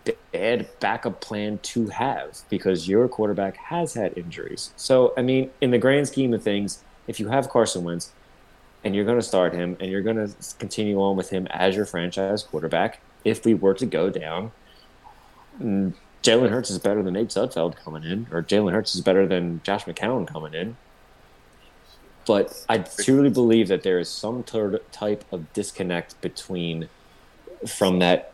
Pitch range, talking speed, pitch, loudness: 95-115 Hz, 175 wpm, 105 Hz, -24 LUFS